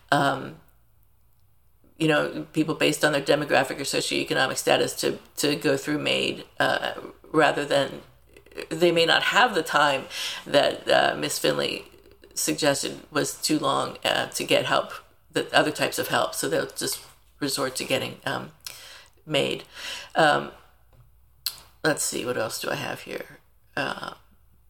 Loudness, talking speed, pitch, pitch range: -24 LUFS, 145 wpm, 155 Hz, 145-170 Hz